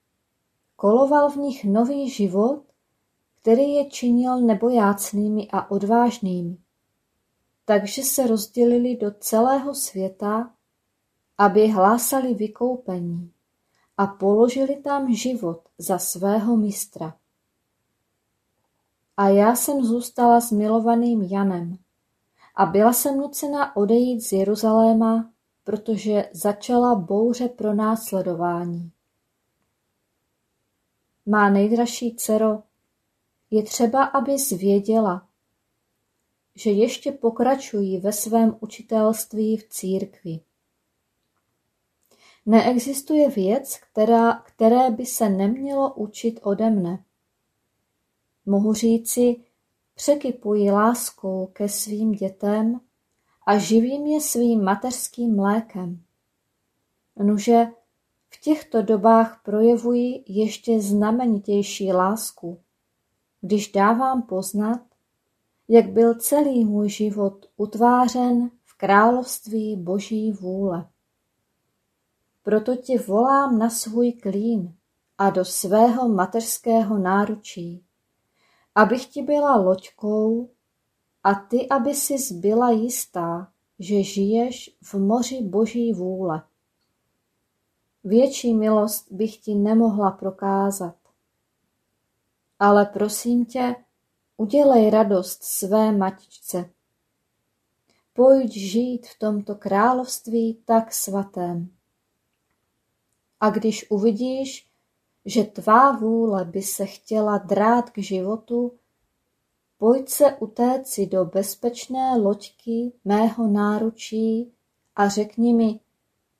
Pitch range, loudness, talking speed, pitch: 195-240 Hz, -21 LUFS, 90 wpm, 215 Hz